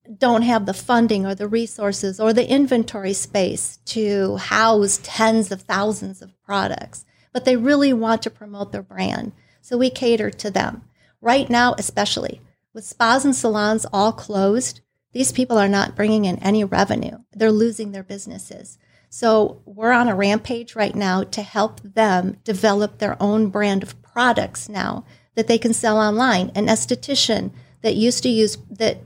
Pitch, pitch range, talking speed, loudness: 220 Hz, 205-235 Hz, 165 wpm, -19 LUFS